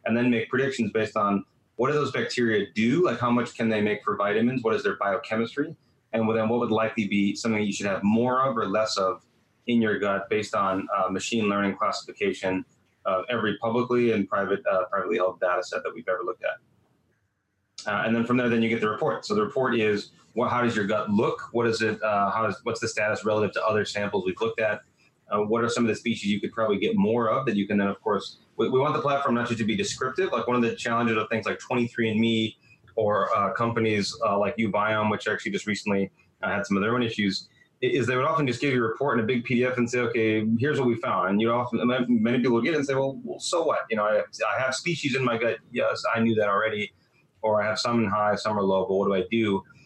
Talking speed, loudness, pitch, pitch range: 260 wpm, -25 LUFS, 115 Hz, 105-120 Hz